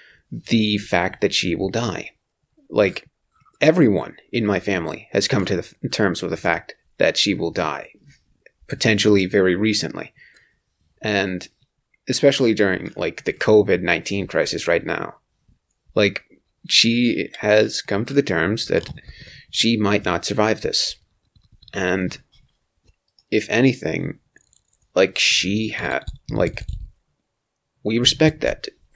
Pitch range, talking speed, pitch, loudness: 90-110 Hz, 125 wpm, 100 Hz, -20 LUFS